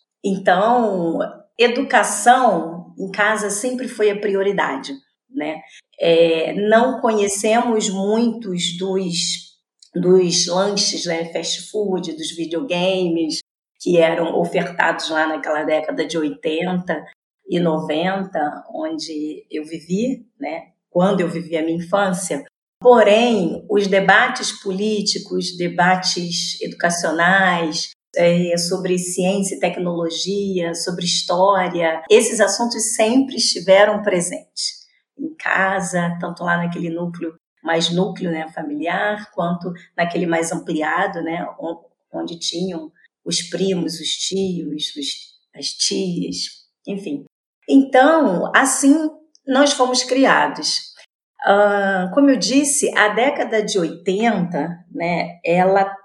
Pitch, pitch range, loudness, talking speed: 185 Hz, 170-215 Hz, -18 LUFS, 105 wpm